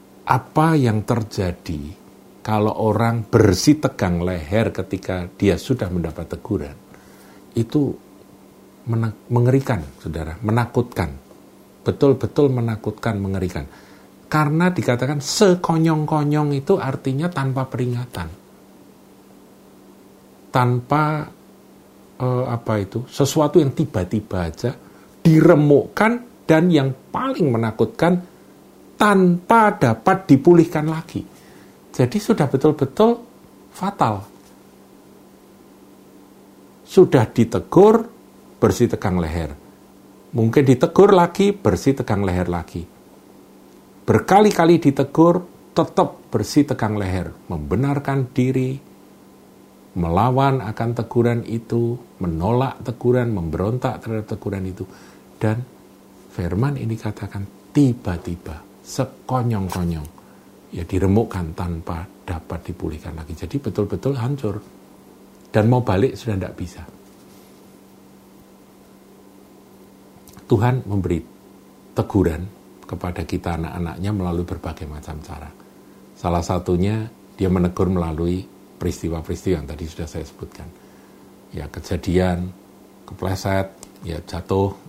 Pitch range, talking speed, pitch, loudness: 90-135 Hz, 90 wpm, 110 Hz, -20 LUFS